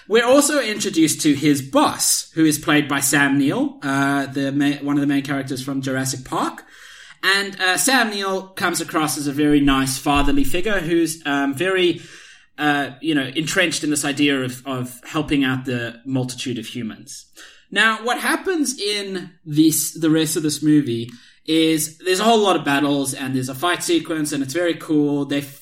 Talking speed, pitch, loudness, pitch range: 190 wpm, 150 Hz, -19 LUFS, 140-175 Hz